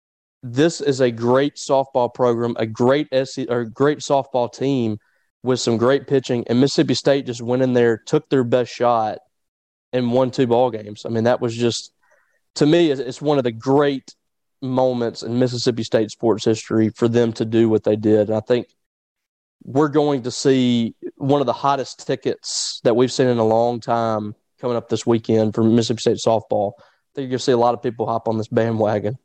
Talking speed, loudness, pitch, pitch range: 205 wpm, -19 LUFS, 120 Hz, 115-135 Hz